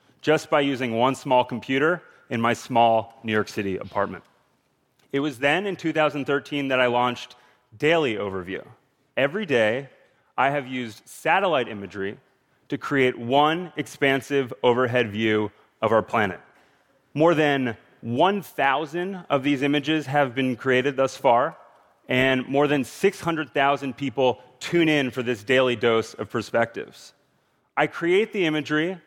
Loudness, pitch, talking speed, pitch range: -23 LUFS, 135 Hz, 140 wpm, 125-150 Hz